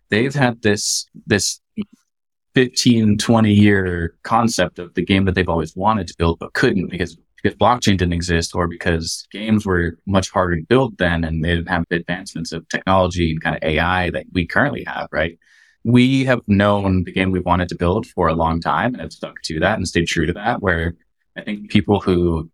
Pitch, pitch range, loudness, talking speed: 90 Hz, 85-105 Hz, -18 LUFS, 205 wpm